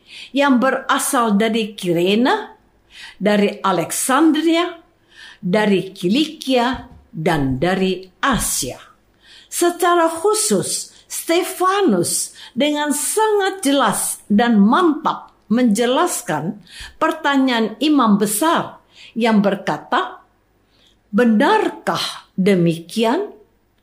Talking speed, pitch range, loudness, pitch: 70 wpm, 205-330 Hz, -17 LUFS, 255 Hz